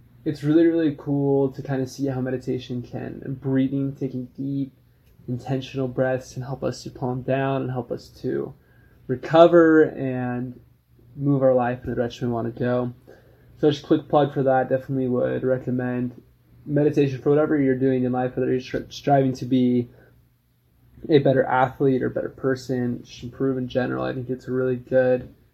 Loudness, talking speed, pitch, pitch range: -23 LUFS, 180 wpm, 130 Hz, 125-135 Hz